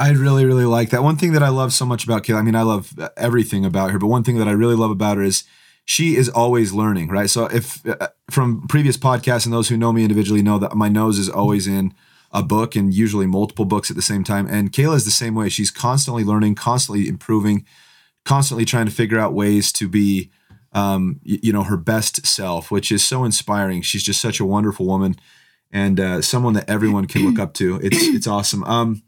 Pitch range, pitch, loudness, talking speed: 100-120 Hz, 110 Hz, -18 LUFS, 235 wpm